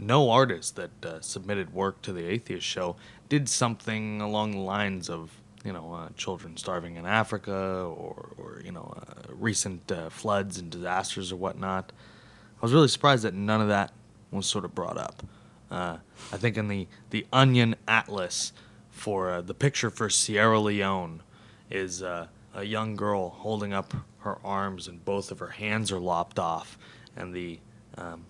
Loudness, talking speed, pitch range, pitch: -28 LUFS, 175 wpm, 95-110 Hz, 100 Hz